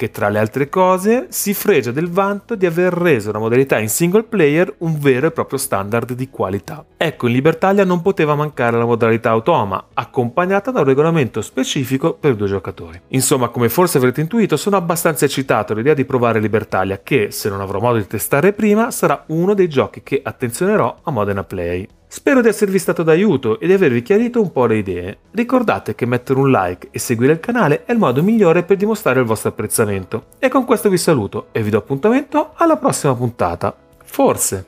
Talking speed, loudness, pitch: 195 wpm, -16 LUFS, 140 Hz